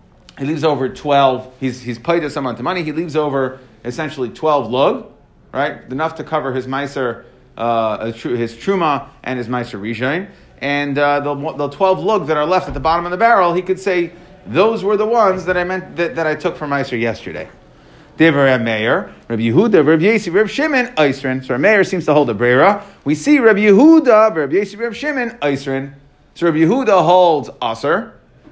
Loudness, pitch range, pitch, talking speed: -16 LUFS, 130-185 Hz, 155 Hz, 190 wpm